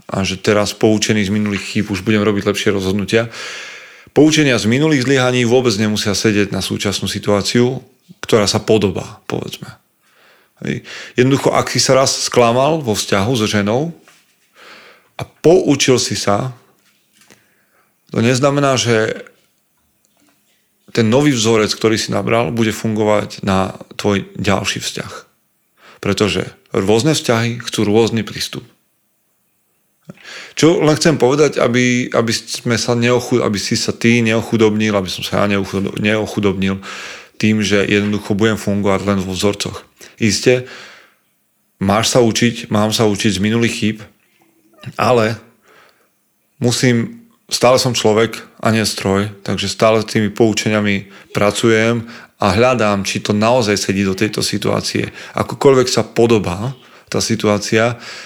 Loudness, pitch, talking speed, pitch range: -15 LUFS, 110 Hz, 135 wpm, 105-120 Hz